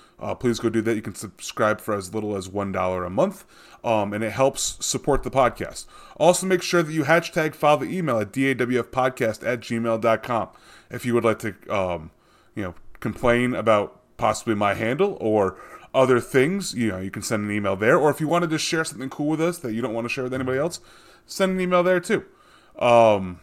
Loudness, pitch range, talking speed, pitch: -23 LUFS, 110-150 Hz, 220 wpm, 120 Hz